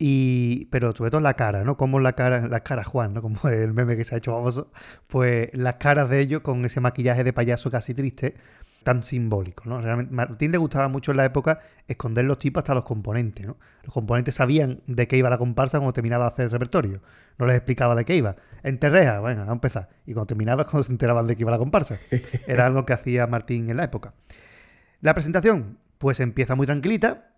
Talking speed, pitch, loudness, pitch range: 225 wpm, 125 Hz, -23 LUFS, 120-135 Hz